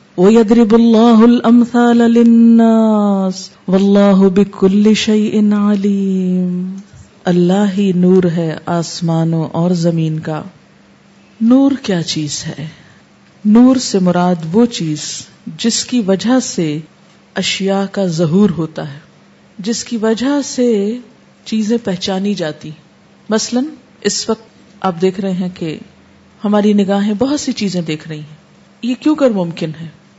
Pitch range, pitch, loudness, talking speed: 175-230 Hz, 200 Hz, -13 LUFS, 115 wpm